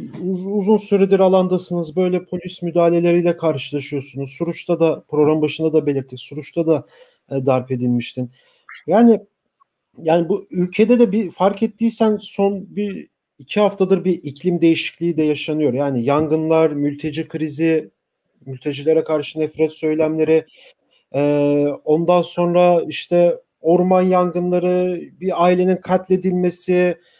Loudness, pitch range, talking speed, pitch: -18 LUFS, 155-185 Hz, 115 wpm, 170 Hz